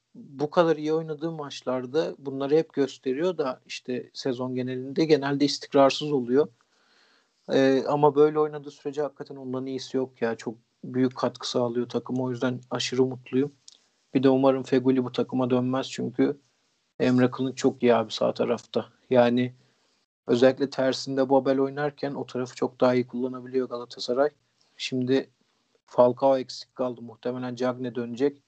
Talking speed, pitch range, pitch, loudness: 145 wpm, 125-140 Hz, 130 Hz, -26 LUFS